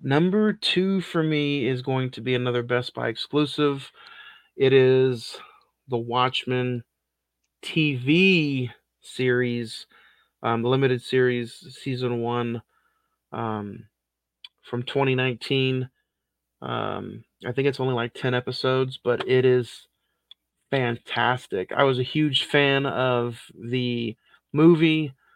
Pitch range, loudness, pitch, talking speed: 120-140 Hz, -24 LUFS, 130 Hz, 110 wpm